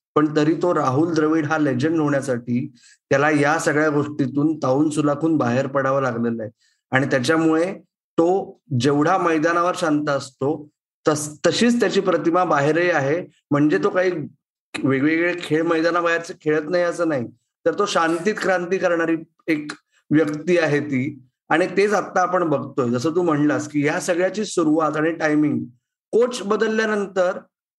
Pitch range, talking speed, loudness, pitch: 145-175 Hz, 145 wpm, -20 LUFS, 160 Hz